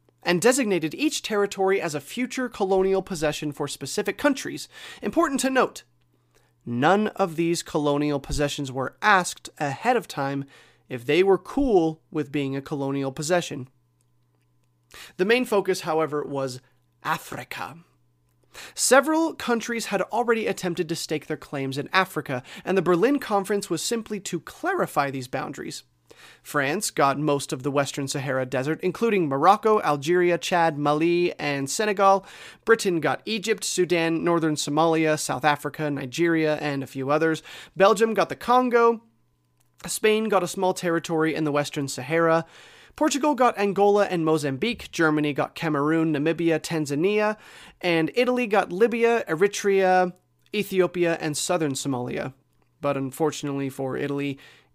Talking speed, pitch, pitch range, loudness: 135 wpm, 165 Hz, 145-200 Hz, -24 LUFS